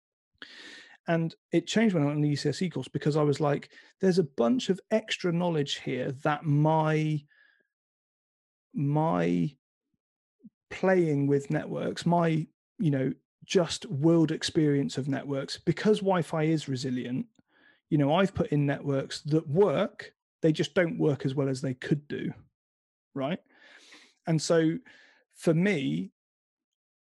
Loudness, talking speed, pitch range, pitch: -28 LUFS, 135 wpm, 145-185 Hz, 160 Hz